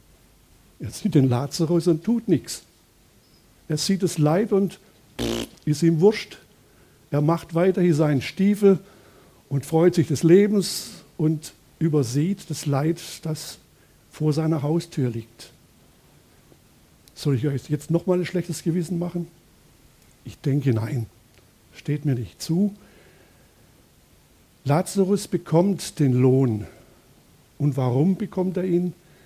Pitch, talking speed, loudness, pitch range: 165 Hz, 120 wpm, -23 LUFS, 140-180 Hz